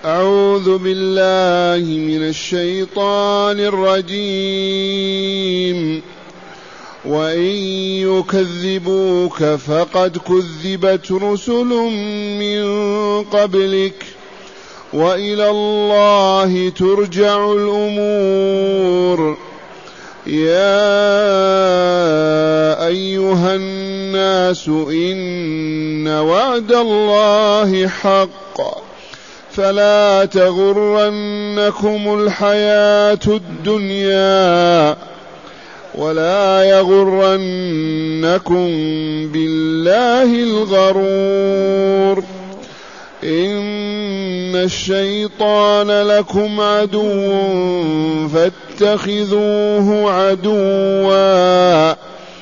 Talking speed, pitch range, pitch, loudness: 40 wpm, 180-205 Hz, 195 Hz, -14 LUFS